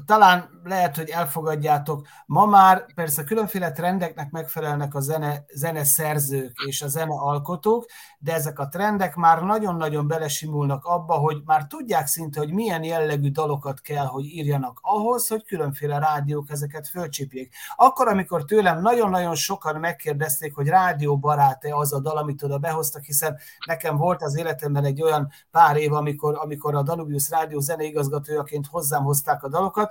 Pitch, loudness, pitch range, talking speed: 155 Hz, -22 LUFS, 145-170 Hz, 155 wpm